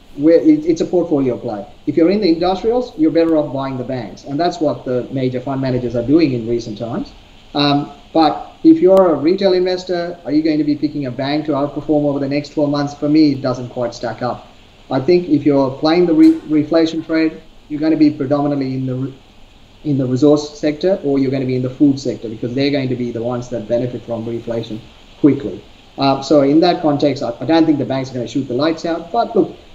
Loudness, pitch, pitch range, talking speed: -16 LUFS, 145 Hz, 125-160 Hz, 240 wpm